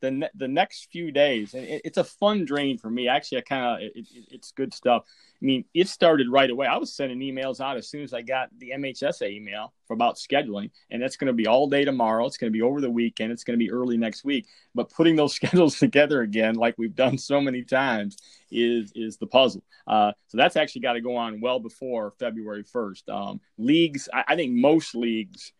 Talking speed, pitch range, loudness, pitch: 235 wpm, 115-145 Hz, -24 LUFS, 130 Hz